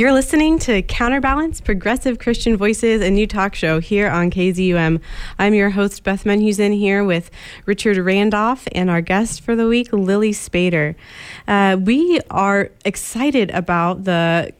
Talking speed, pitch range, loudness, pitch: 150 wpm, 185-230 Hz, -17 LUFS, 205 Hz